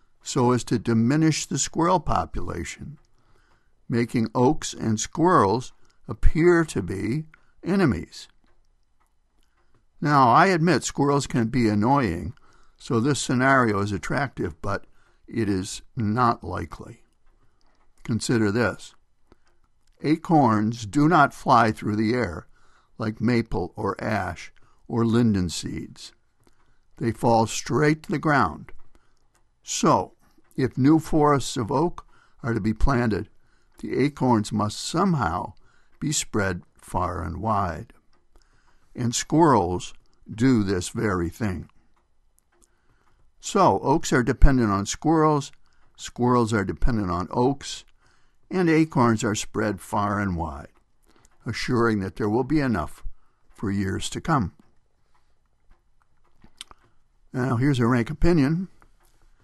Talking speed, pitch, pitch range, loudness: 115 wpm, 115 Hz, 105-140 Hz, -23 LUFS